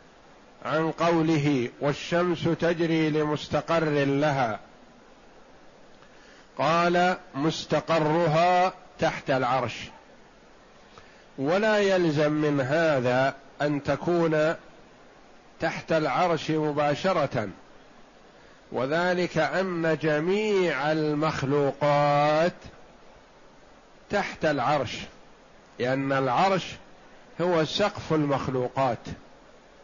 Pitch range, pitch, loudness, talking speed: 145-170 Hz, 155 Hz, -25 LUFS, 60 wpm